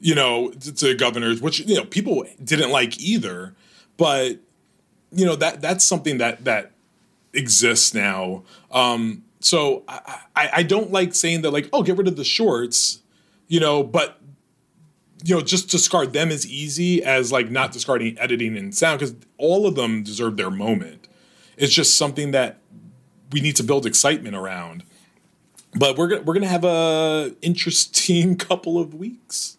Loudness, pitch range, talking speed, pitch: -19 LUFS, 130-185 Hz, 165 wpm, 160 Hz